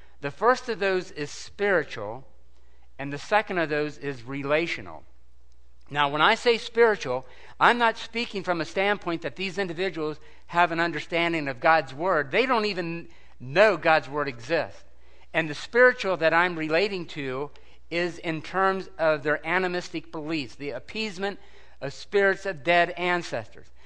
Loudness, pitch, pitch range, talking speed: -25 LUFS, 165 Hz, 145-190 Hz, 155 wpm